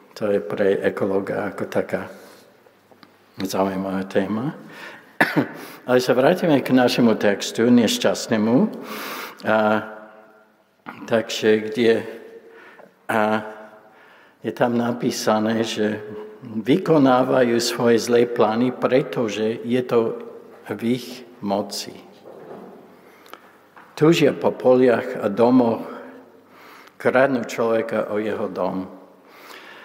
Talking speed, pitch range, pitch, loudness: 85 wpm, 110-125 Hz, 115 Hz, -20 LUFS